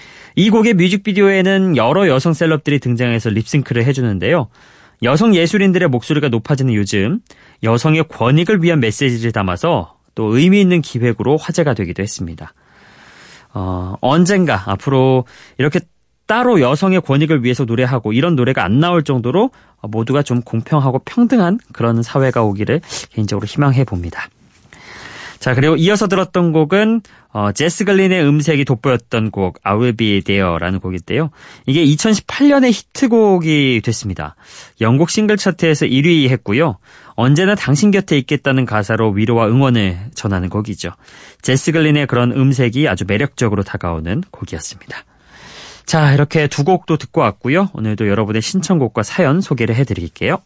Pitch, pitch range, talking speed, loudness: 135 Hz, 110-170 Hz, 355 characters per minute, -15 LUFS